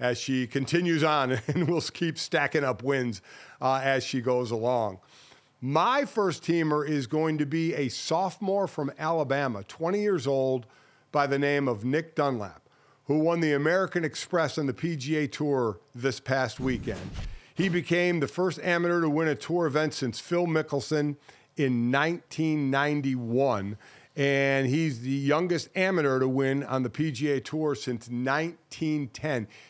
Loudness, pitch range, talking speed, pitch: -27 LUFS, 130-160 Hz, 150 wpm, 145 Hz